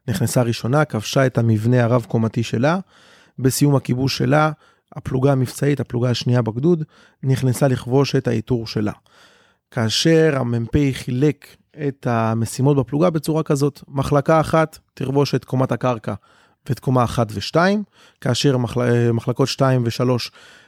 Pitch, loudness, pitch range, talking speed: 130 Hz, -19 LUFS, 120-145 Hz, 125 wpm